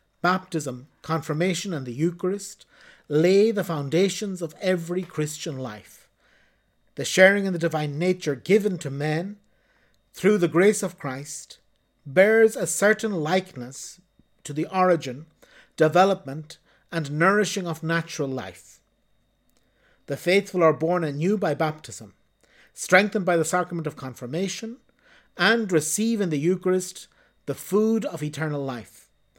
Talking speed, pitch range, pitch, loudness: 125 wpm, 150-190 Hz, 170 Hz, -23 LUFS